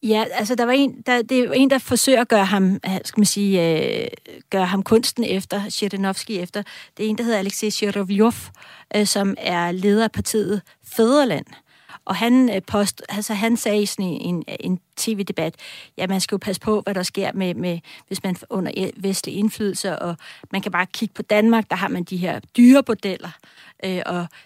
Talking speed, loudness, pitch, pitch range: 200 wpm, -20 LUFS, 205 Hz, 190-225 Hz